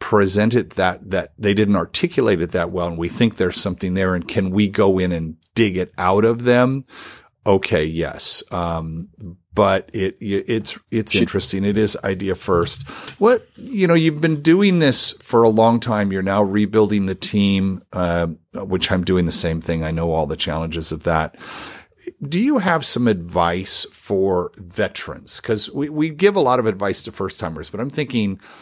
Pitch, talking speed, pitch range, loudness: 100 Hz, 185 wpm, 90-115 Hz, -19 LUFS